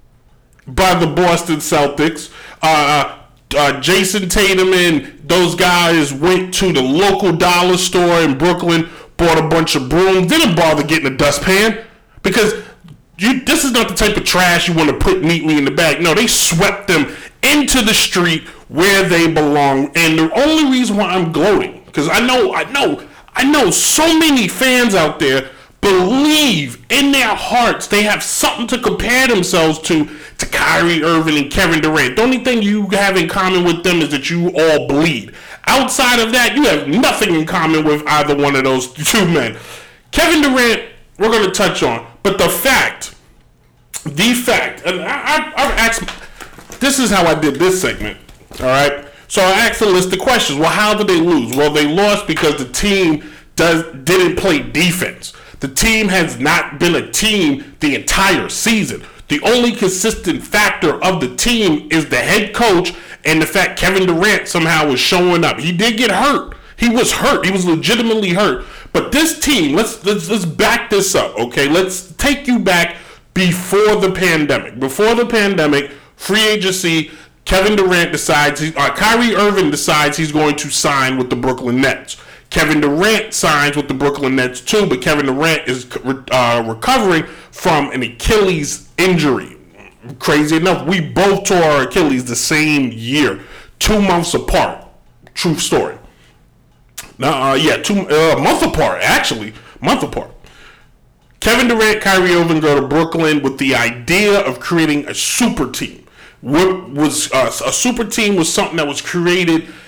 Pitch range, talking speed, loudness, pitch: 150-210 Hz, 170 wpm, -13 LUFS, 175 Hz